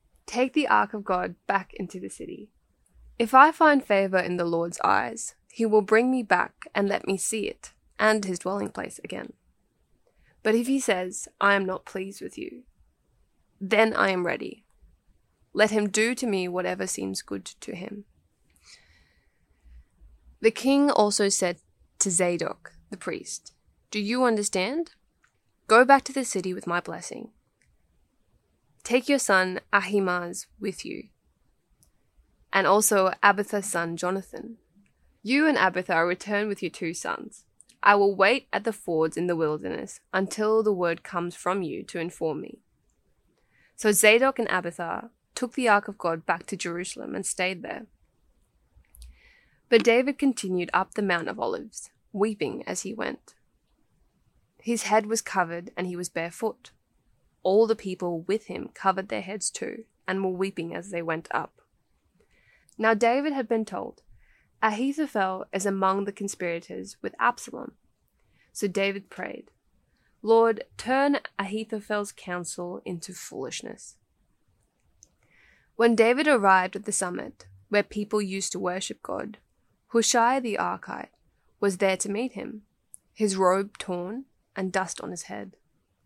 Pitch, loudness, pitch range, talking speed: 195 Hz, -25 LUFS, 175-220 Hz, 150 wpm